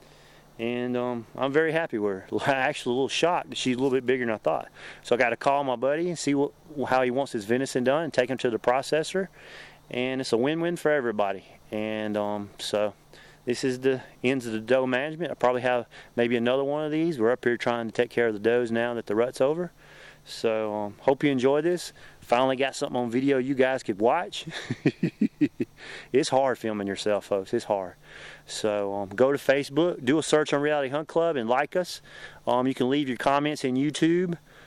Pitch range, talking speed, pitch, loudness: 120-145 Hz, 220 wpm, 130 Hz, -26 LUFS